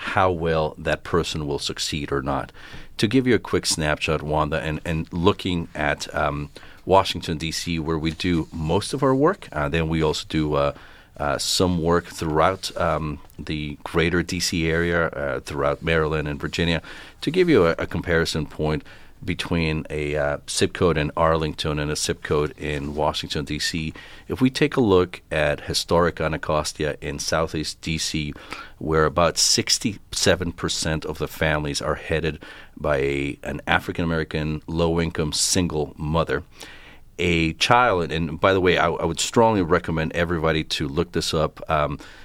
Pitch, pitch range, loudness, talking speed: 80 Hz, 75-85 Hz, -23 LUFS, 165 wpm